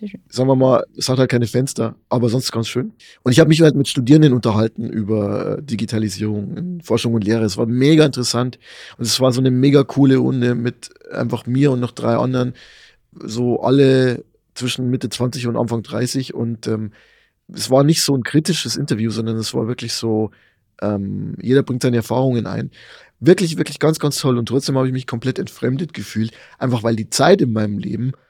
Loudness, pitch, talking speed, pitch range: -18 LUFS, 125 Hz, 195 wpm, 115-135 Hz